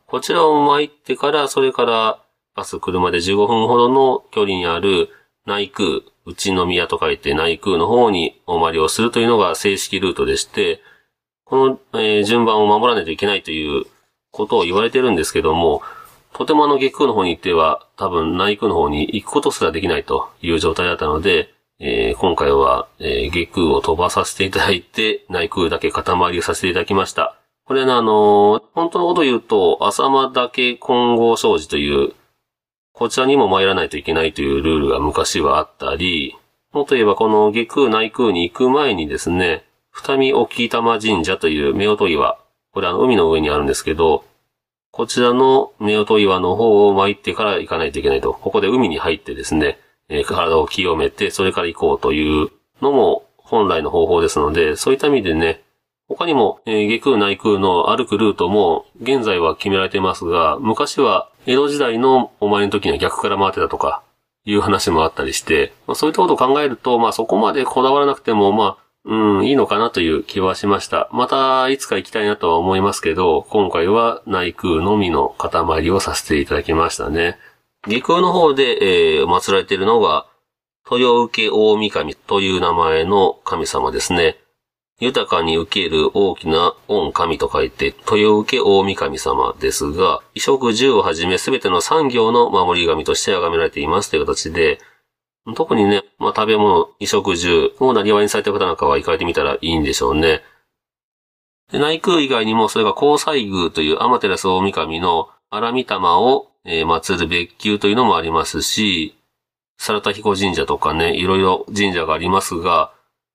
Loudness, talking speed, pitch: -16 LUFS, 360 characters per minute, 130 Hz